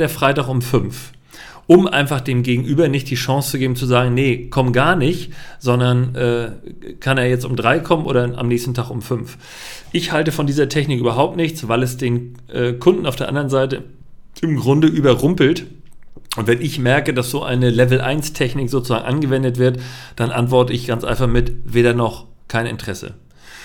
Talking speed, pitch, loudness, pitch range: 190 wpm, 130 Hz, -17 LUFS, 120-140 Hz